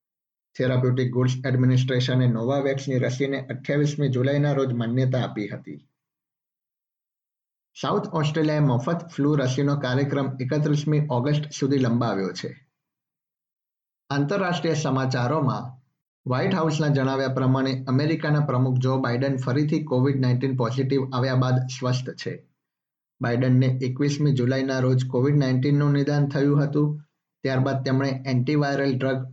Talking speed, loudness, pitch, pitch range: 65 wpm, -23 LUFS, 135 Hz, 130-145 Hz